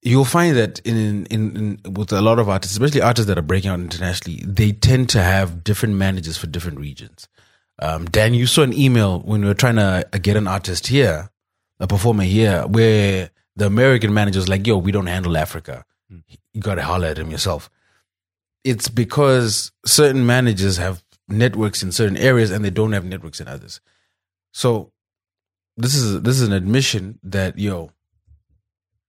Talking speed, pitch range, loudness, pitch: 185 wpm, 90-115 Hz, -18 LUFS, 100 Hz